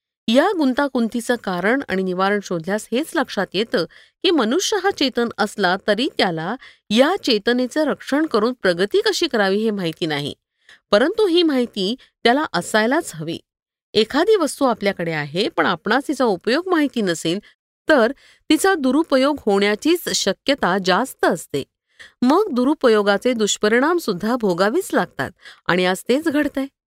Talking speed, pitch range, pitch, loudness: 135 wpm, 195-285 Hz, 240 Hz, -19 LUFS